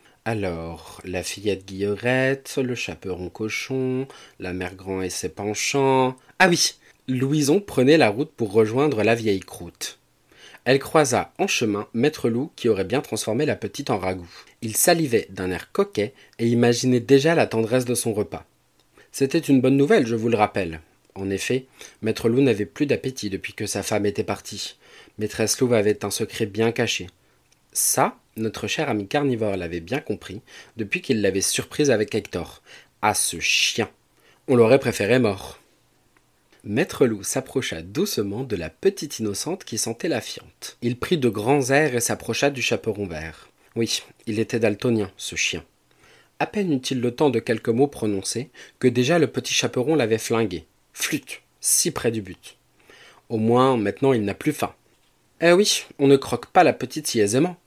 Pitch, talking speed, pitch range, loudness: 115 Hz, 175 wpm, 105-135 Hz, -22 LUFS